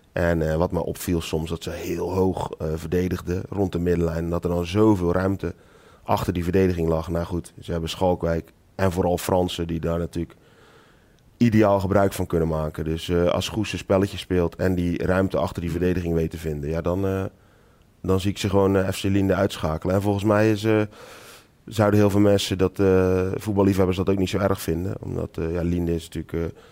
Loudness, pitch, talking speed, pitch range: -23 LUFS, 90 Hz, 210 wpm, 85-100 Hz